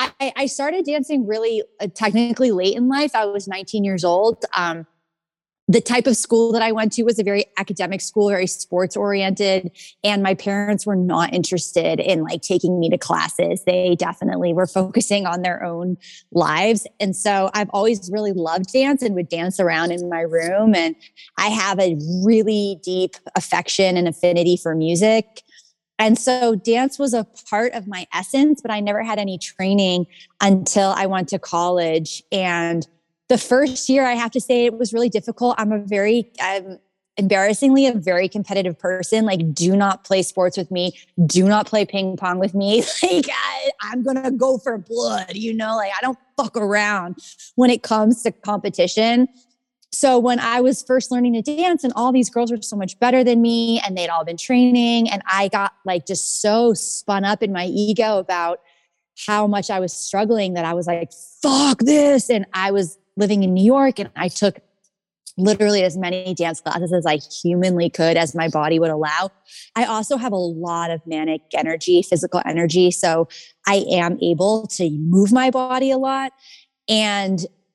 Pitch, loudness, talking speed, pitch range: 200 Hz, -19 LUFS, 185 wpm, 180-230 Hz